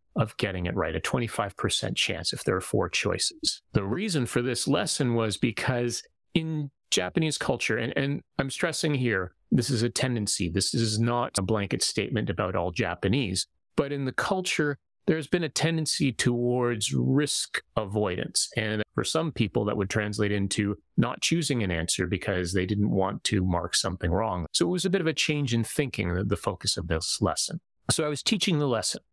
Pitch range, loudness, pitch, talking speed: 100-145 Hz, -27 LUFS, 120 Hz, 190 wpm